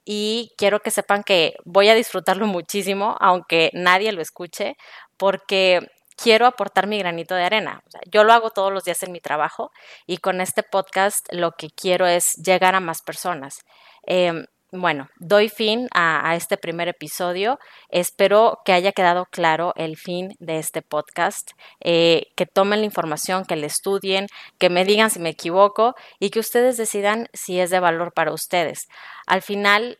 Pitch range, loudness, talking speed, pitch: 175-205 Hz, -20 LUFS, 175 wpm, 185 Hz